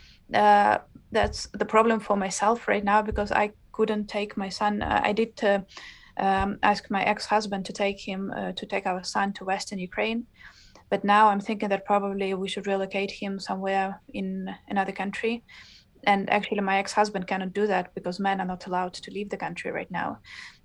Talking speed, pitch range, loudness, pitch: 185 wpm, 195-210 Hz, -26 LUFS, 200 Hz